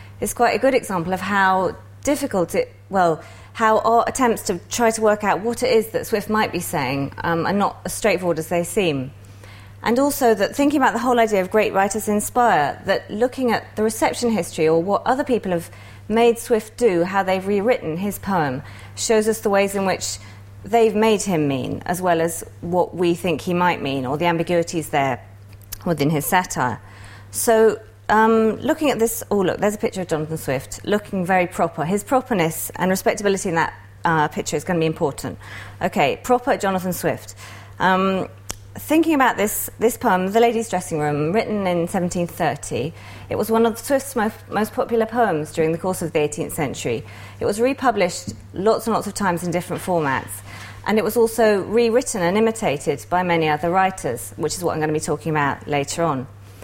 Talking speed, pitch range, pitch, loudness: 195 wpm, 155-225 Hz, 185 Hz, -20 LUFS